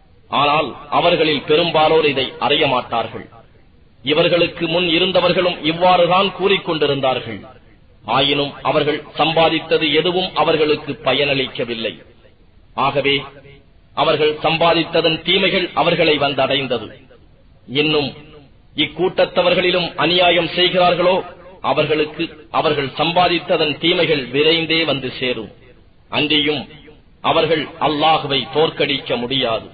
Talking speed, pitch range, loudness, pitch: 80 wpm, 135-170 Hz, -16 LUFS, 150 Hz